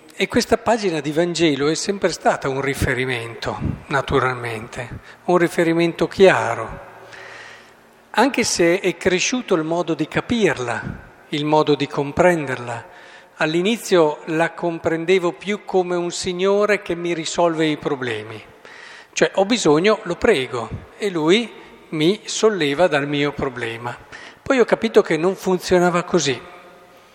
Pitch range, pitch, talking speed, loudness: 150-190 Hz, 170 Hz, 125 wpm, -19 LUFS